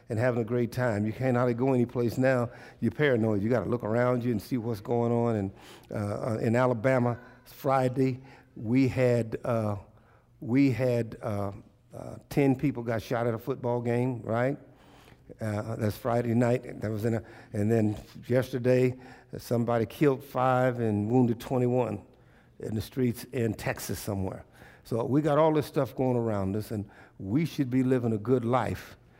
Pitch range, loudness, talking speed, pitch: 110-130 Hz, -28 LUFS, 175 wpm, 120 Hz